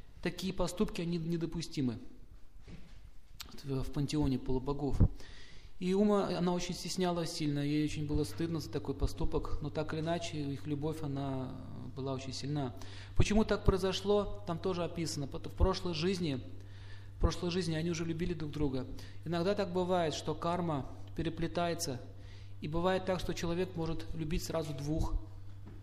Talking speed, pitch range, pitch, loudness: 145 wpm, 130-175 Hz, 155 Hz, -36 LUFS